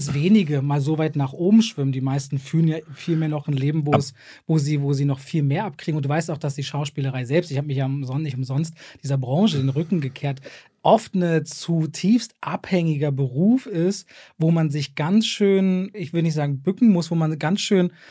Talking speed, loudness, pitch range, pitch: 220 wpm, -22 LUFS, 140-175 Hz, 155 Hz